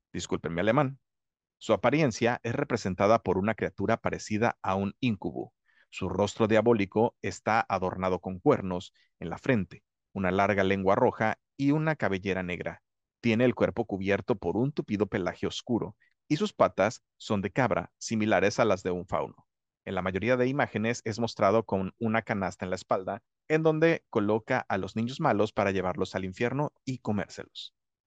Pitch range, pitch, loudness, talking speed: 95-125 Hz, 110 Hz, -29 LUFS, 165 wpm